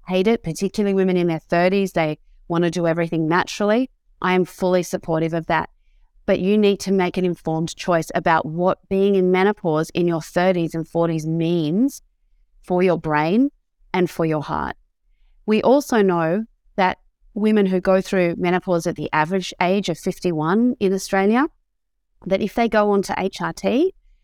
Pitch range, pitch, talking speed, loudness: 170-200 Hz, 185 Hz, 170 wpm, -20 LUFS